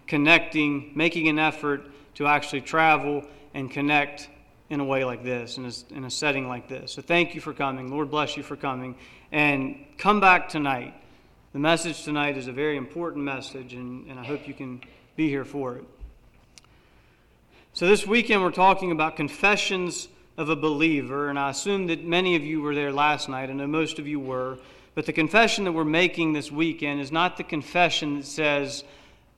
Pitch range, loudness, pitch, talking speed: 135-160 Hz, -24 LUFS, 145 Hz, 190 wpm